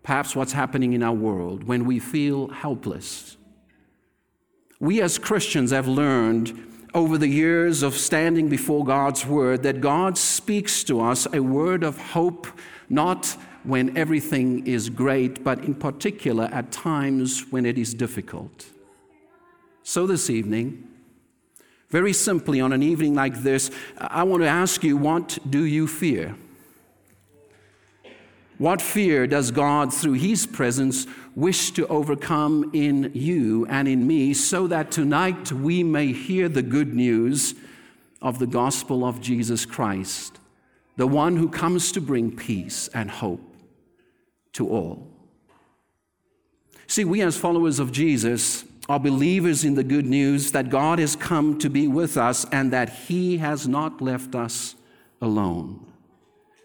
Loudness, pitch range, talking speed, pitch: -22 LUFS, 125-165 Hz, 140 wpm, 140 Hz